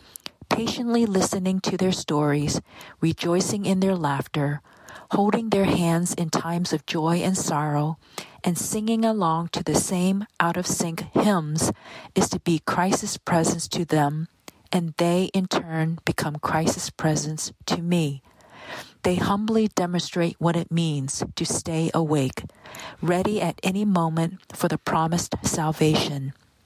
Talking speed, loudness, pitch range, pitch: 135 wpm, -24 LUFS, 160-190 Hz, 170 Hz